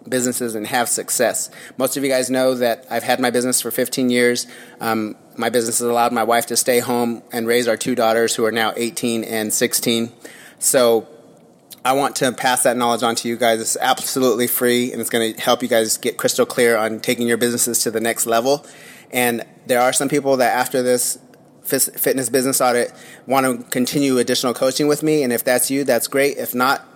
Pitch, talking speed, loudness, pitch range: 120 Hz, 215 wpm, -18 LUFS, 115-130 Hz